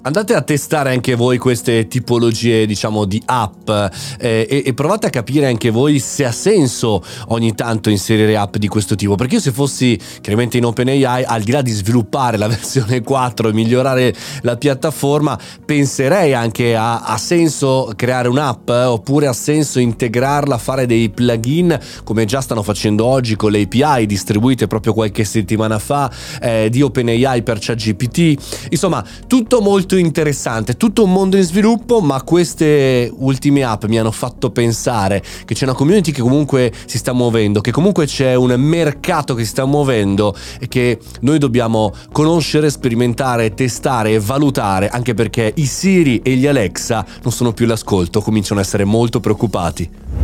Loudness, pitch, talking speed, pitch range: -15 LUFS, 125 Hz, 165 wpm, 110-140 Hz